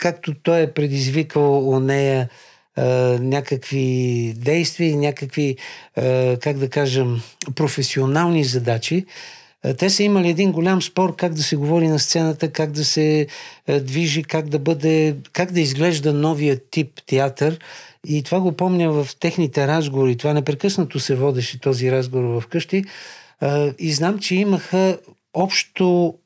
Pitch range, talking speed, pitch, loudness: 135-170 Hz, 135 wpm, 150 Hz, -19 LUFS